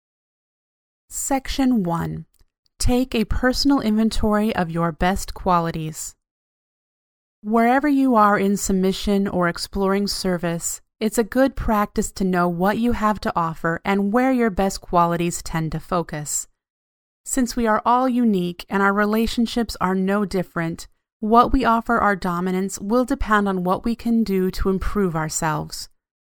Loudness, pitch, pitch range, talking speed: -21 LUFS, 200 Hz, 175-230 Hz, 145 wpm